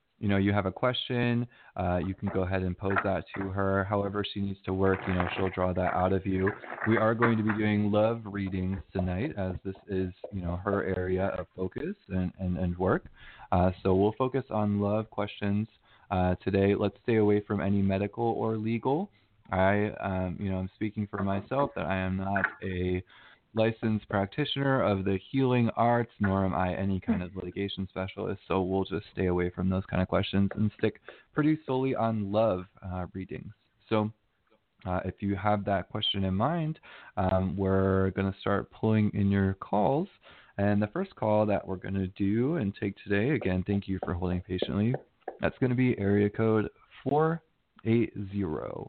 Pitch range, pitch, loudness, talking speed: 95-110 Hz, 100 Hz, -30 LUFS, 190 wpm